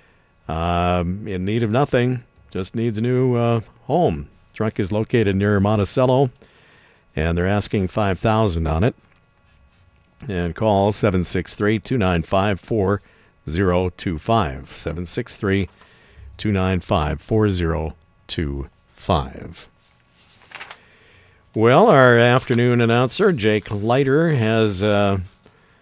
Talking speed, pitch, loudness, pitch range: 90 wpm, 100 Hz, -20 LUFS, 90-115 Hz